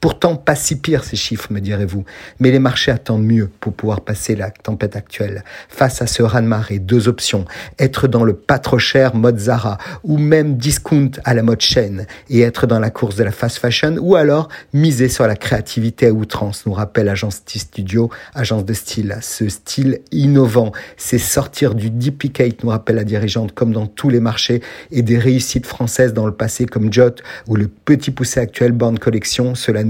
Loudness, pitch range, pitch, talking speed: -16 LUFS, 110-130 Hz, 120 Hz, 190 wpm